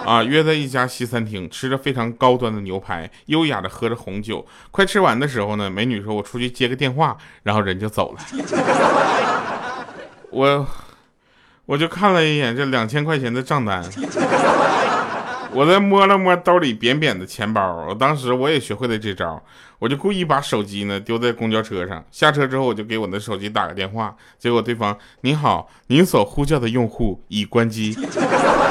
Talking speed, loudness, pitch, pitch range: 270 characters per minute, -19 LUFS, 120 Hz, 105-145 Hz